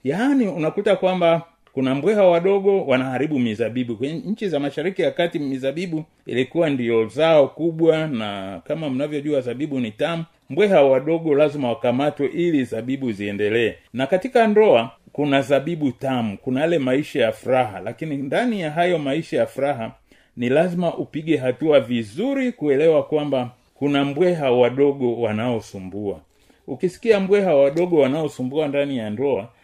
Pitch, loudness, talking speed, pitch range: 145 Hz, -20 LUFS, 135 wpm, 125-170 Hz